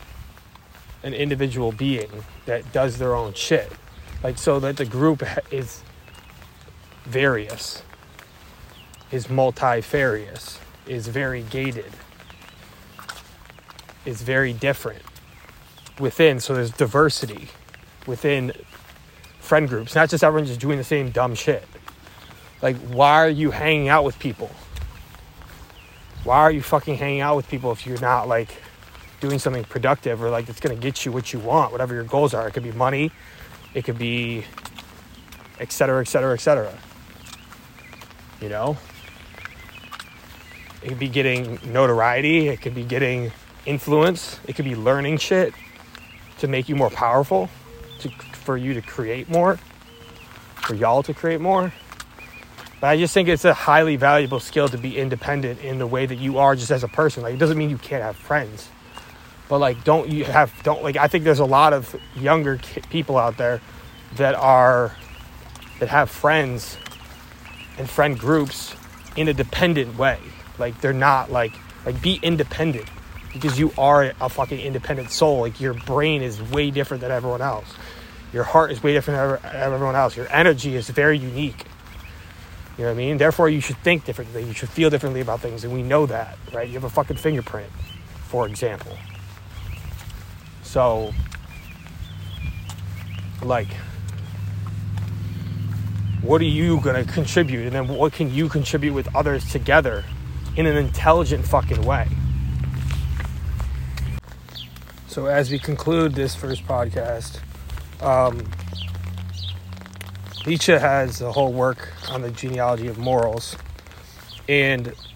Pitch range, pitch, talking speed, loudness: 100-140 Hz, 125 Hz, 145 wpm, -21 LUFS